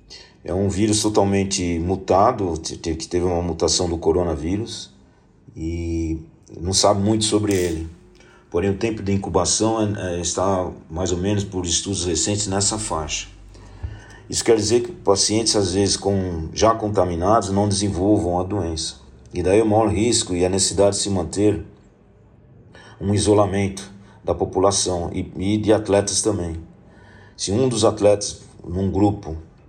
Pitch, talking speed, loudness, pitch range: 100 Hz, 150 wpm, -20 LUFS, 90-105 Hz